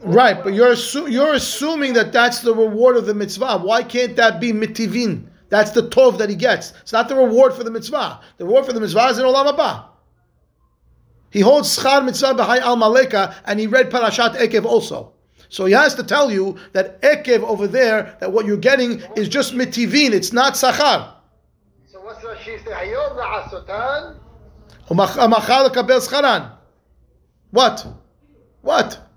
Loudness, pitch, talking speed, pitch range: -16 LUFS, 240 Hz, 165 wpm, 220-265 Hz